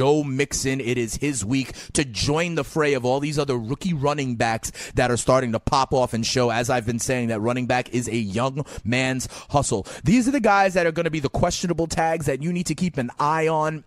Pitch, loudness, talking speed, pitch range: 135 Hz, -23 LUFS, 245 wpm, 120-155 Hz